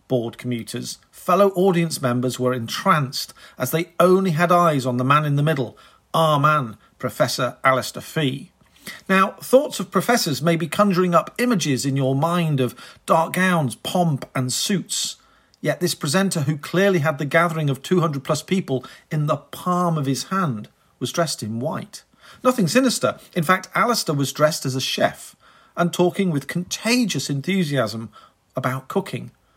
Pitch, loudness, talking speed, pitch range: 160 Hz, -21 LUFS, 160 wpm, 130-185 Hz